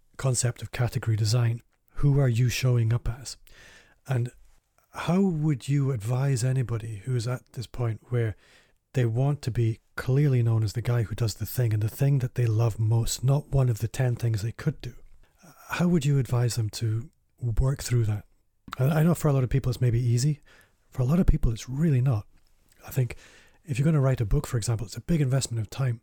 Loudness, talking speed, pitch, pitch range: -27 LUFS, 220 wpm, 120 Hz, 115-135 Hz